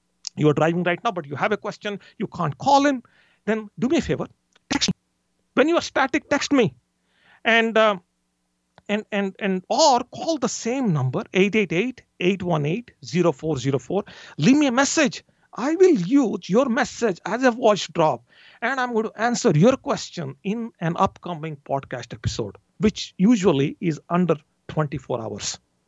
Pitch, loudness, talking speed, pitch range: 200 Hz, -22 LUFS, 165 wpm, 160-235 Hz